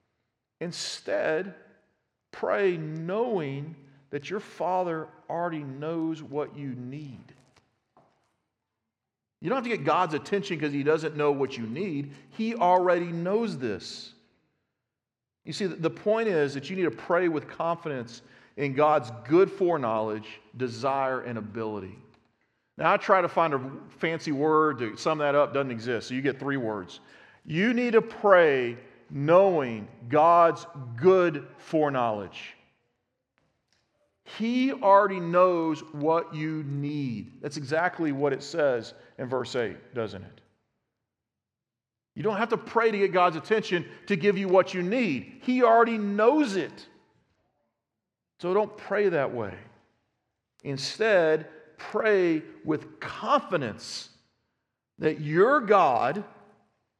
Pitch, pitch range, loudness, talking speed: 155 Hz, 130-185 Hz, -26 LUFS, 130 wpm